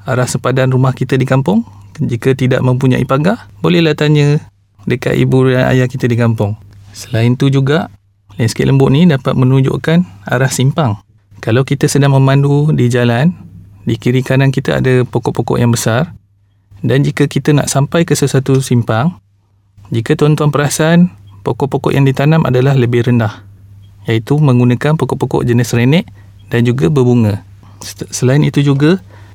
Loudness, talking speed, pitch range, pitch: -12 LUFS, 145 wpm, 110-140 Hz, 130 Hz